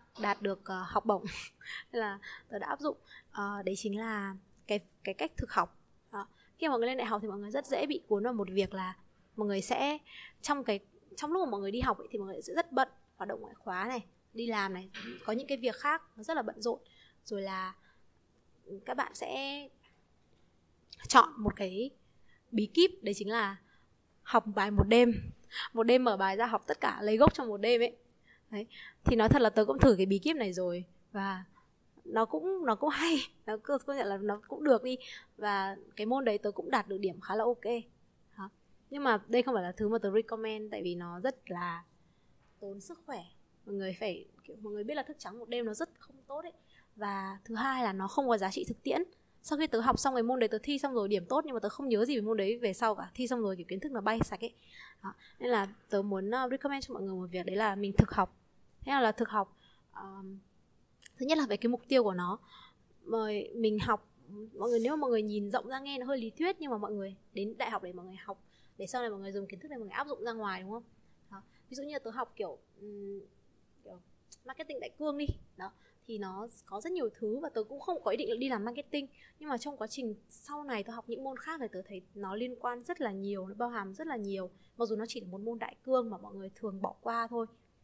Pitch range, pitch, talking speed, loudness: 200-255 Hz, 225 Hz, 255 wpm, -34 LUFS